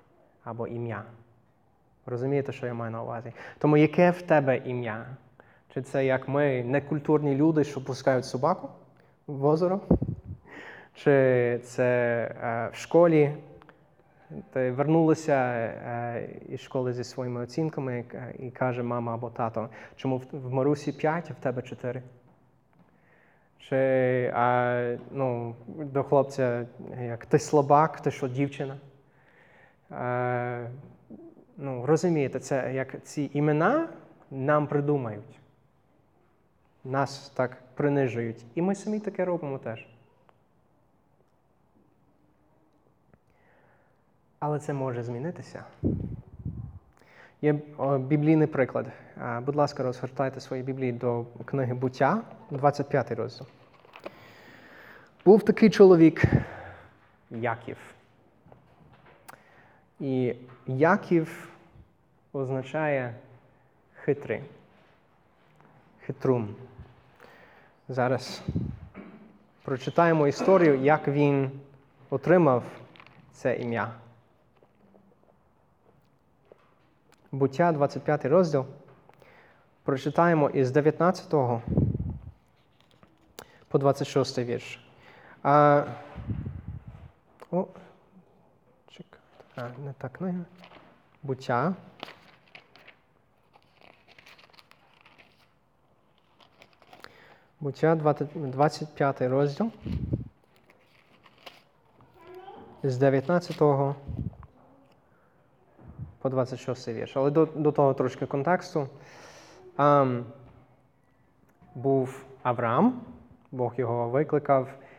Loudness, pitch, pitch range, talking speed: -27 LUFS, 135 Hz, 125-150 Hz, 75 wpm